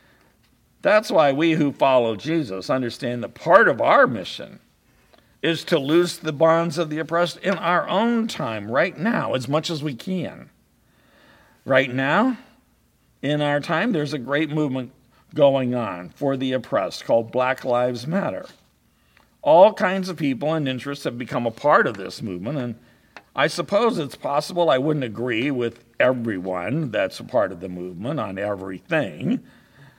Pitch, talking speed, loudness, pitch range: 140 Hz, 160 wpm, -22 LUFS, 125-165 Hz